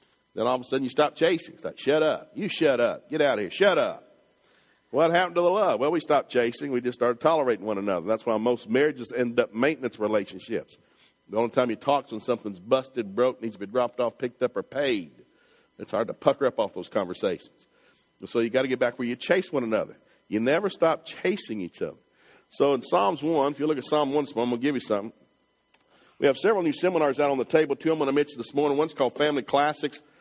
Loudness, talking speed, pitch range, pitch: -26 LUFS, 250 wpm, 120-150 Hz, 130 Hz